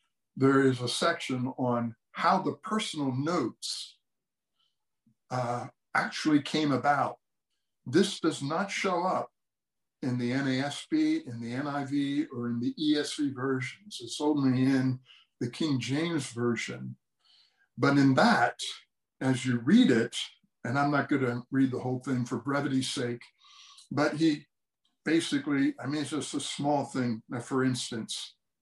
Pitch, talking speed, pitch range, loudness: 135 Hz, 145 wpm, 125-150 Hz, -29 LUFS